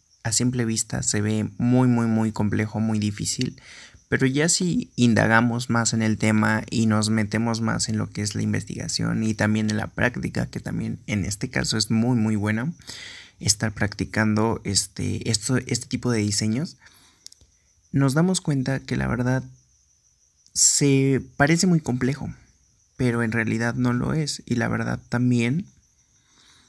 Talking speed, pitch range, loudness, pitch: 160 wpm, 105-125 Hz, -23 LUFS, 115 Hz